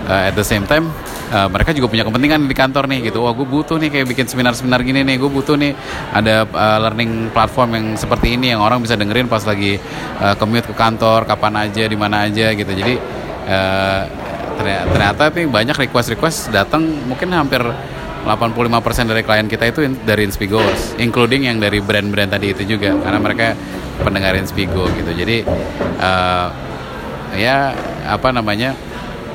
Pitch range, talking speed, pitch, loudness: 100-125 Hz, 170 wpm, 110 Hz, -15 LUFS